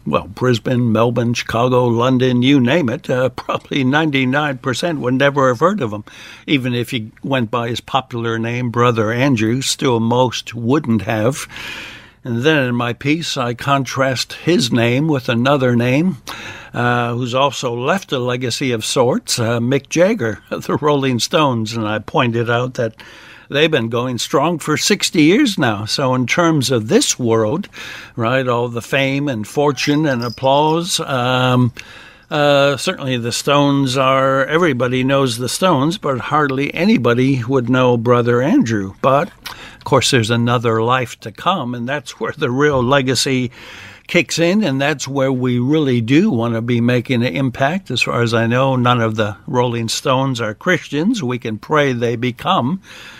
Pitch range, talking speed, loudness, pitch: 120-140 Hz, 165 wpm, -16 LUFS, 125 Hz